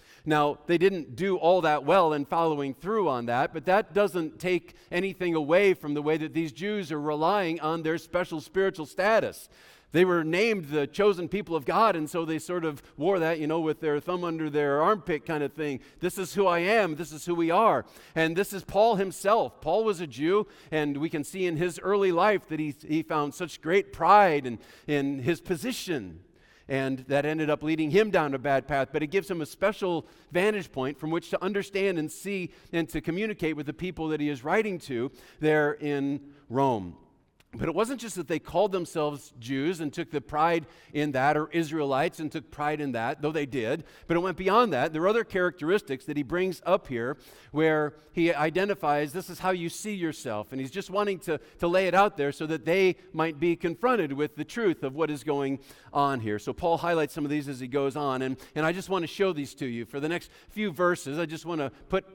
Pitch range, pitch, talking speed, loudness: 150-185 Hz, 160 Hz, 230 wpm, -28 LUFS